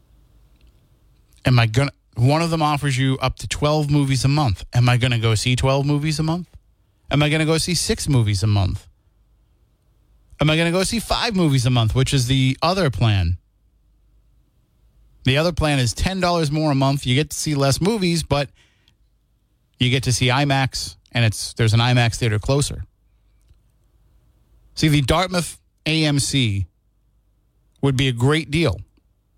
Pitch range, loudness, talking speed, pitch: 105-150 Hz, -19 LUFS, 165 wpm, 130 Hz